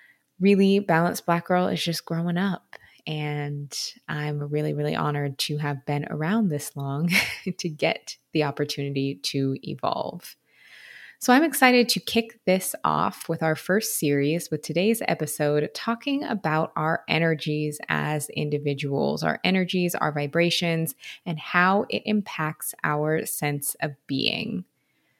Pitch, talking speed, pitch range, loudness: 160 Hz, 135 wpm, 145-185 Hz, -25 LUFS